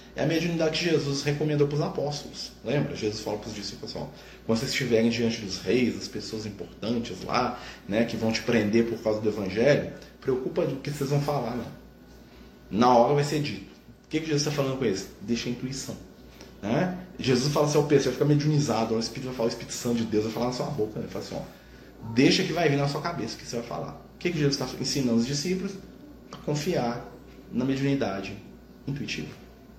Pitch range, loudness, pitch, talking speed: 115-145 Hz, -27 LUFS, 130 Hz, 225 wpm